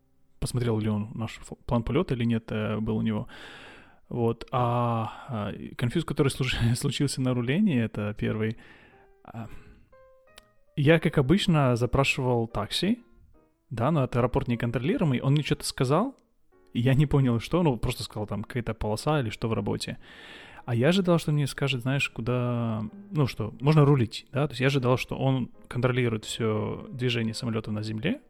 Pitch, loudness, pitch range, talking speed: 125 Hz, -27 LUFS, 110-145 Hz, 160 wpm